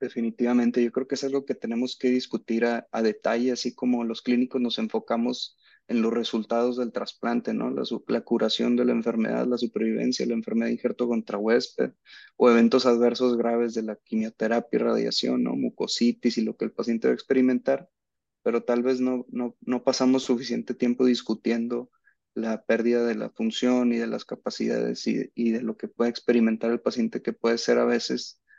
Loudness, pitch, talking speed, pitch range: -26 LUFS, 120 Hz, 195 wpm, 115-125 Hz